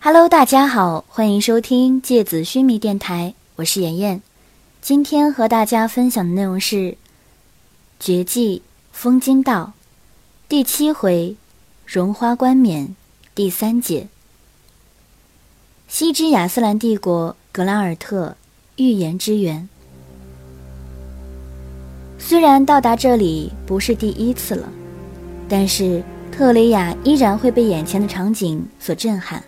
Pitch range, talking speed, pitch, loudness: 175-245 Hz, 180 characters per minute, 205 Hz, -17 LUFS